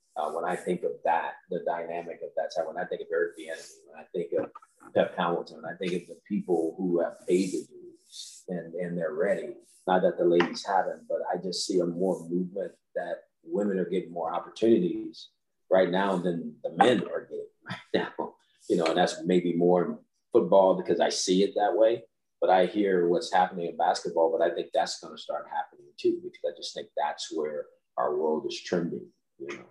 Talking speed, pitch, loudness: 210 wpm, 360 Hz, -28 LUFS